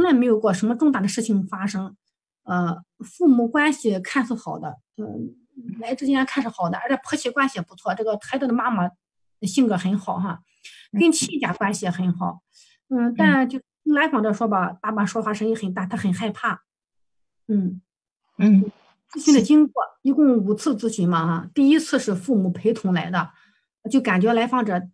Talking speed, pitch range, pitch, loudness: 265 characters per minute, 190-265 Hz, 225 Hz, -21 LUFS